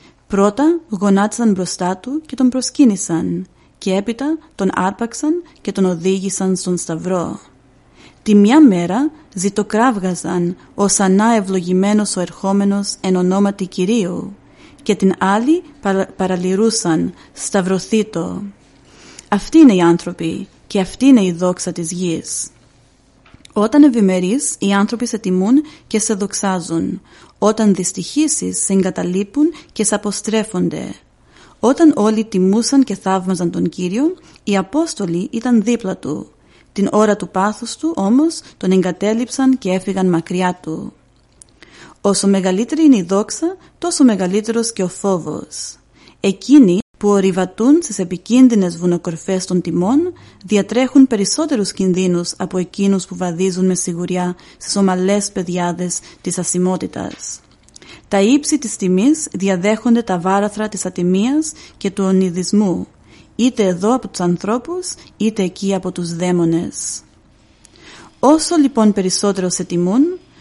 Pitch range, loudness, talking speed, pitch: 185-230 Hz, -16 LUFS, 125 wpm, 195 Hz